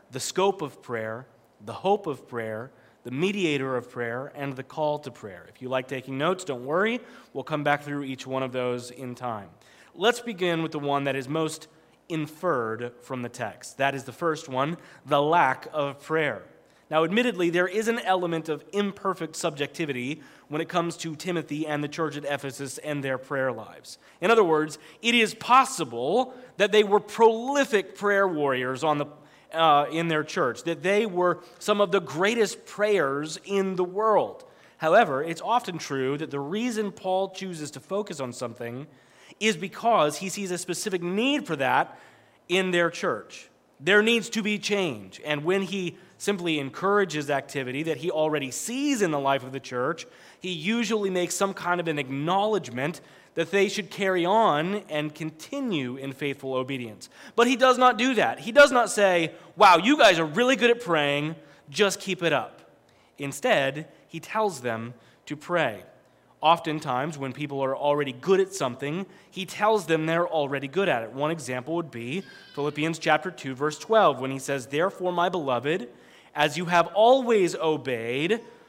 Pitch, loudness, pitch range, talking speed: 160 Hz, -25 LUFS, 140-195 Hz, 180 wpm